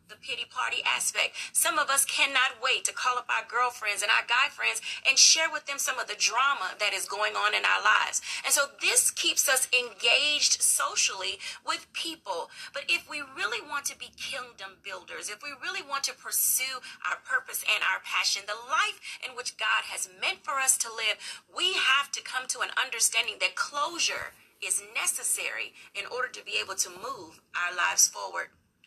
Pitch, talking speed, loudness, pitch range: 275 Hz, 195 wpm, -26 LUFS, 250-330 Hz